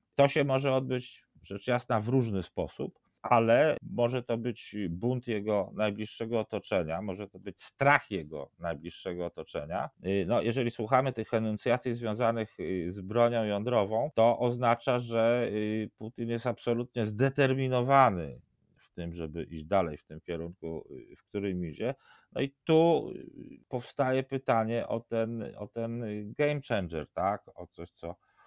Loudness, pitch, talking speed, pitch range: -30 LUFS, 115 Hz, 140 wpm, 95-125 Hz